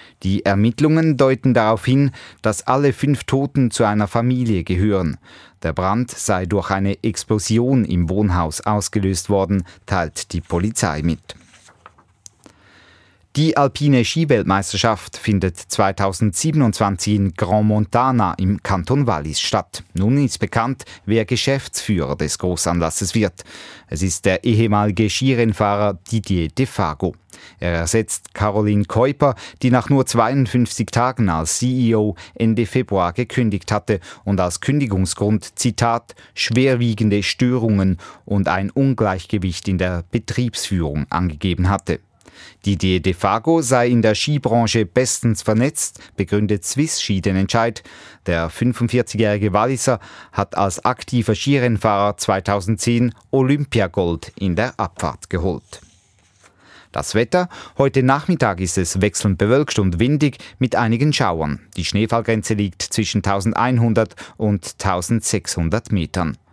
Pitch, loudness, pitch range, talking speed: 105 Hz, -19 LUFS, 95-120 Hz, 120 wpm